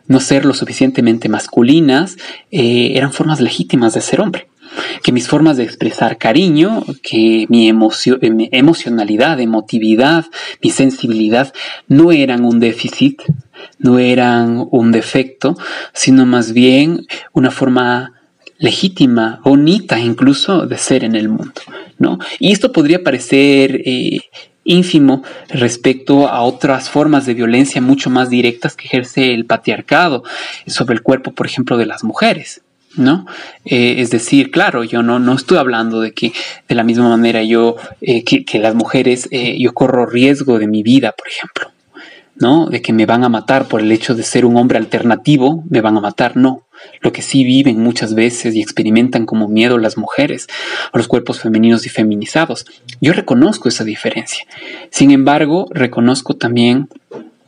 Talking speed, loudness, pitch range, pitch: 160 wpm, -12 LUFS, 115-135 Hz, 125 Hz